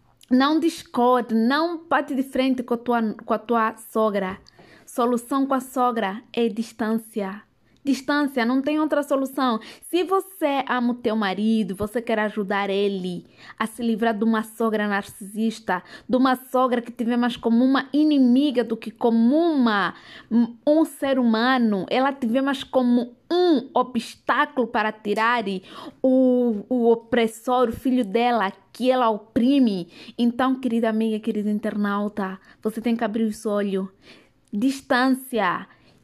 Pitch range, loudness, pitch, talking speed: 220-260 Hz, -22 LUFS, 235 Hz, 145 wpm